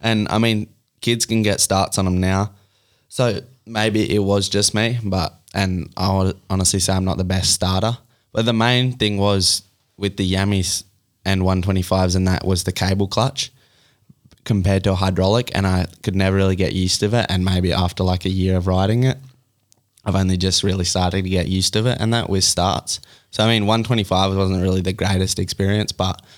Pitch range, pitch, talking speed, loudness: 95-110 Hz, 100 Hz, 200 wpm, -19 LUFS